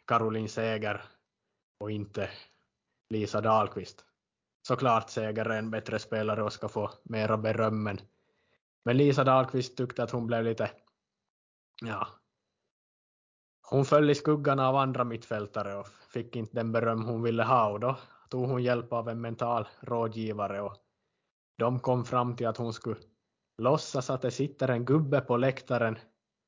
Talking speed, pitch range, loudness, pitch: 150 wpm, 110-125 Hz, -30 LUFS, 115 Hz